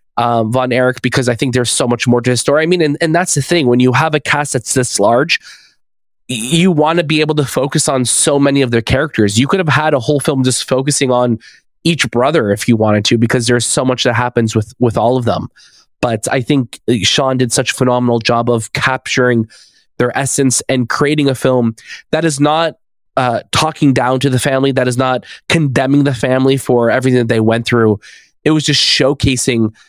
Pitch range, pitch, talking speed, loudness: 120-145 Hz, 130 Hz, 220 wpm, -13 LUFS